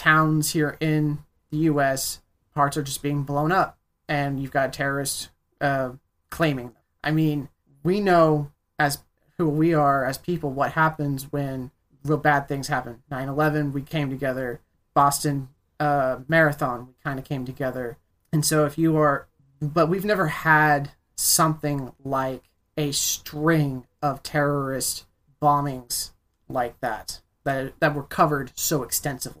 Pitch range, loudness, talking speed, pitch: 135-155 Hz, -24 LUFS, 145 wpm, 145 Hz